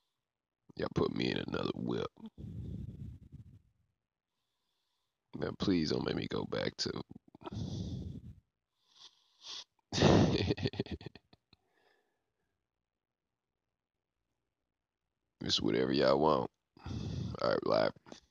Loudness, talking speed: -34 LUFS, 65 wpm